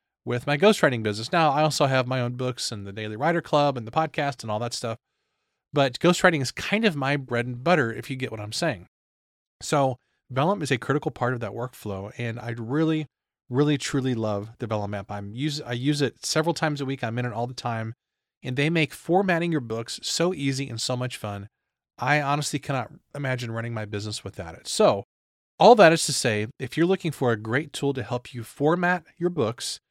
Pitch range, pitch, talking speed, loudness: 115-150 Hz, 130 Hz, 225 wpm, -25 LUFS